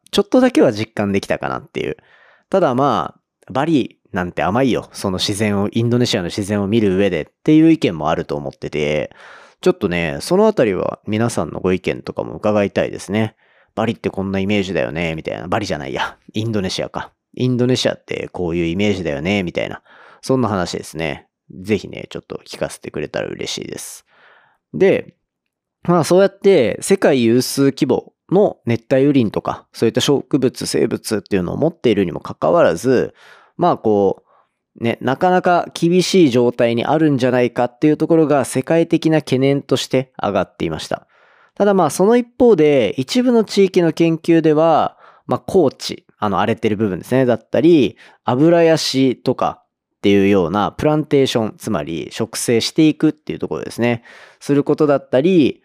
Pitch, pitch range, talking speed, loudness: 130 Hz, 110-160 Hz, 380 characters per minute, -17 LUFS